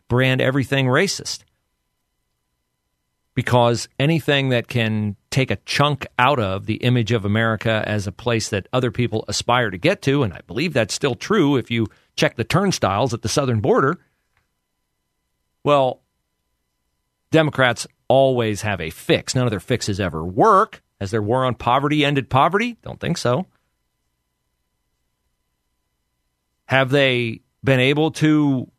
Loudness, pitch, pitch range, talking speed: -19 LUFS, 115 Hz, 80-135 Hz, 140 wpm